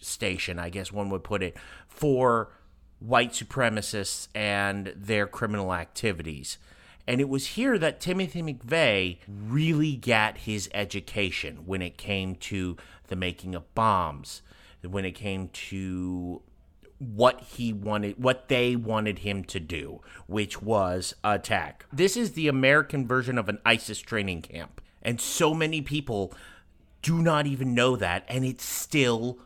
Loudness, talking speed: -27 LUFS, 145 wpm